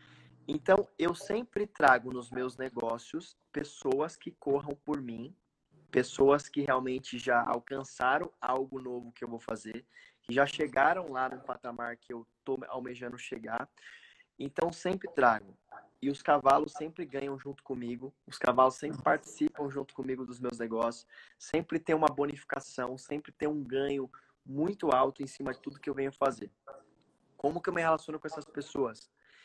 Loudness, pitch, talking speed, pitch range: -32 LUFS, 135 Hz, 160 wpm, 125-150 Hz